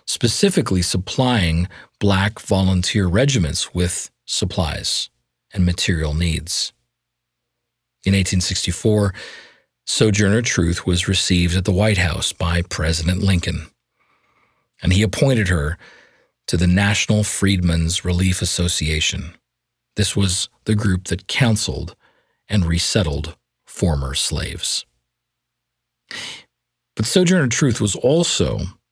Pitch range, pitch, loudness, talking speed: 85-105 Hz, 95 Hz, -19 LUFS, 100 wpm